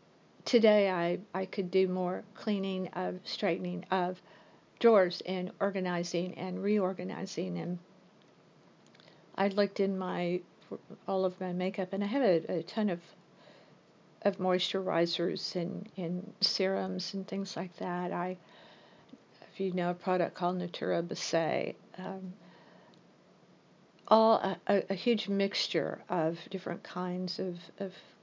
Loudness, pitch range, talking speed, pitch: -32 LUFS, 180-195 Hz, 130 wpm, 185 Hz